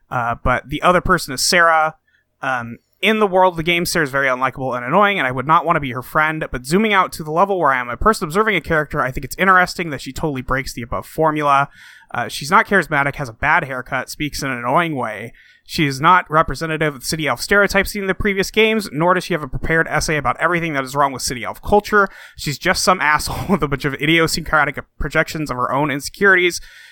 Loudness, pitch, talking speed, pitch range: -17 LUFS, 155 Hz, 245 wpm, 140-185 Hz